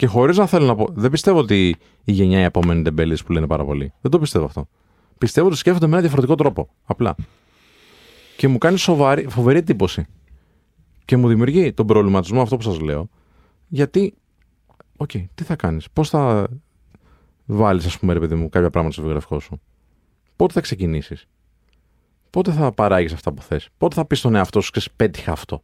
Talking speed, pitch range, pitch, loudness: 190 wpm, 80-135 Hz, 100 Hz, -18 LUFS